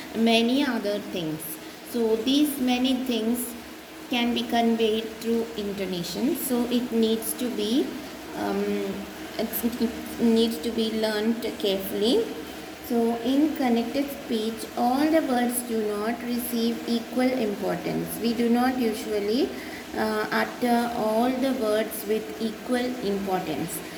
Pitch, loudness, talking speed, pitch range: 235 Hz, -26 LUFS, 120 wpm, 220-250 Hz